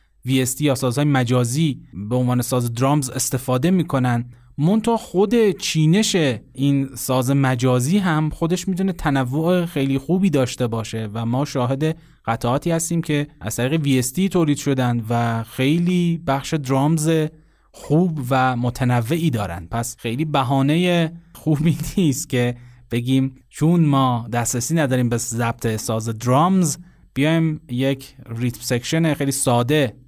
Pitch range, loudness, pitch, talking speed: 125-160 Hz, -20 LUFS, 135 Hz, 130 wpm